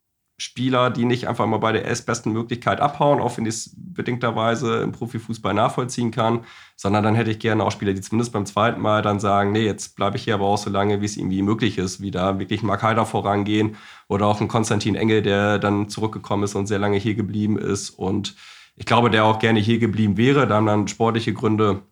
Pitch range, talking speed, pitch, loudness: 100-115 Hz, 225 wpm, 110 Hz, -21 LUFS